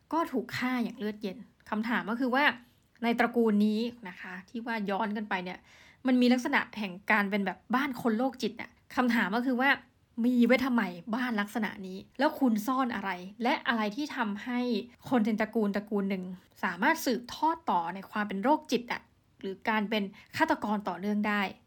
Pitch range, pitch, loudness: 205-250 Hz, 230 Hz, -30 LUFS